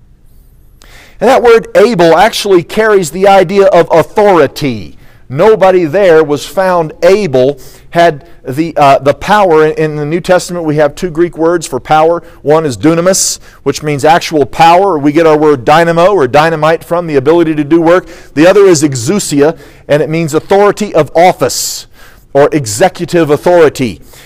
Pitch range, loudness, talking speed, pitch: 150-180 Hz, -8 LUFS, 160 wpm, 165 Hz